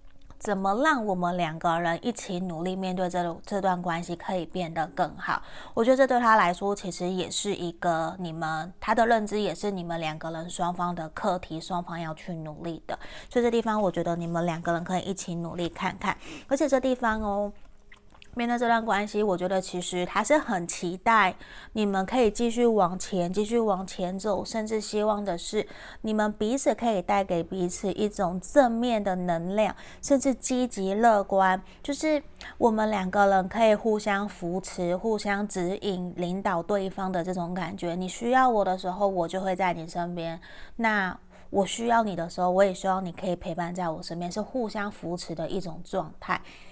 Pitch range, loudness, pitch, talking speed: 175-215 Hz, -27 LUFS, 190 Hz, 285 characters per minute